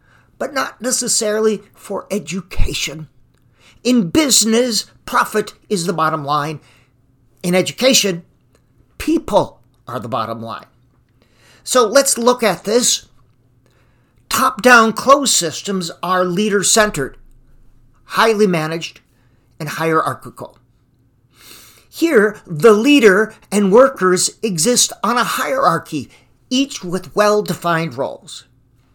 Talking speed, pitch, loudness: 100 wpm, 180 Hz, -15 LUFS